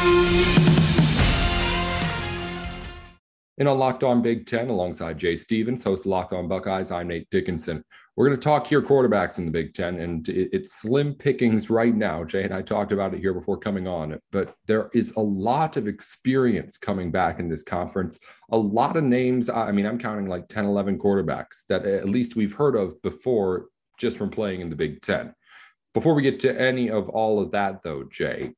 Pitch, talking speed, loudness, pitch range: 105 Hz, 190 wpm, -24 LUFS, 90-125 Hz